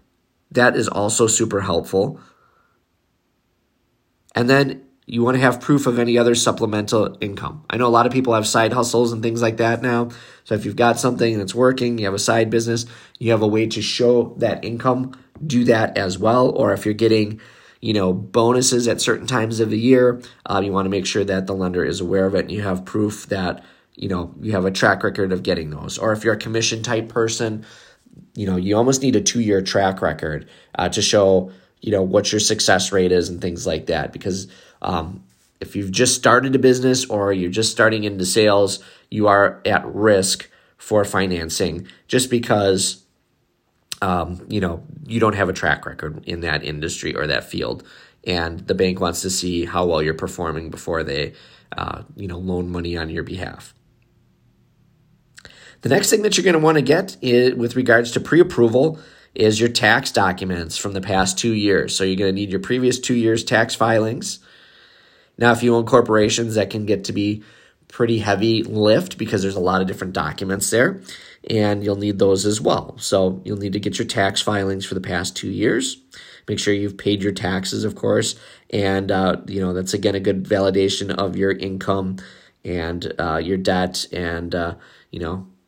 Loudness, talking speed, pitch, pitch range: -19 LUFS, 200 wpm, 105 Hz, 95-115 Hz